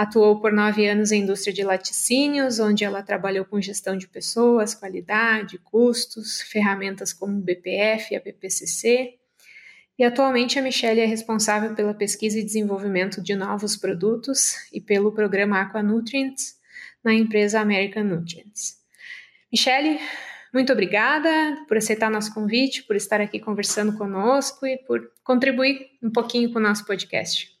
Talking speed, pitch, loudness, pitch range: 145 wpm, 215 Hz, -22 LUFS, 200-245 Hz